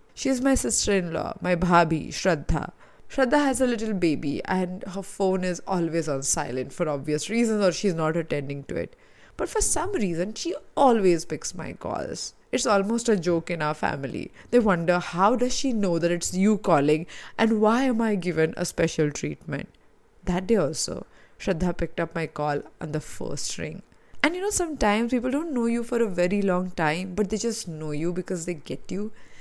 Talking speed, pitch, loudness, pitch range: 200 wpm, 185 Hz, -25 LUFS, 165-225 Hz